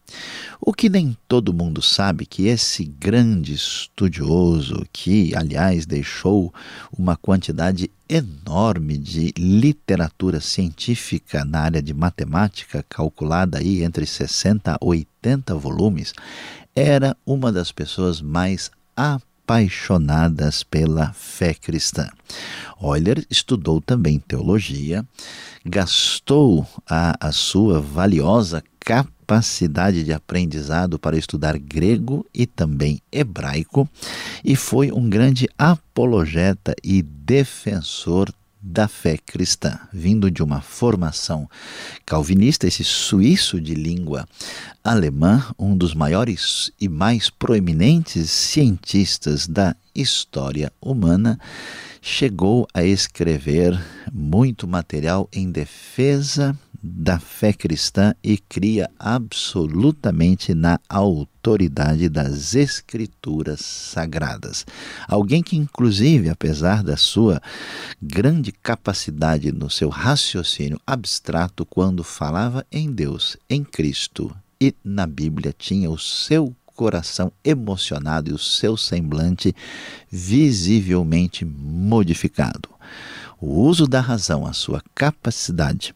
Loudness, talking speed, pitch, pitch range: -20 LUFS, 100 wpm, 95 Hz, 80-115 Hz